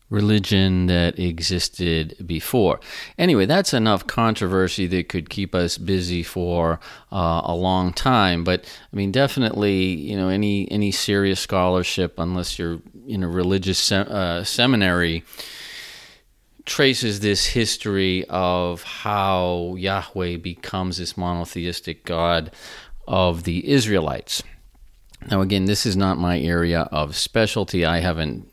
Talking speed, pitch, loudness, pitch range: 125 wpm, 90 Hz, -21 LUFS, 85-100 Hz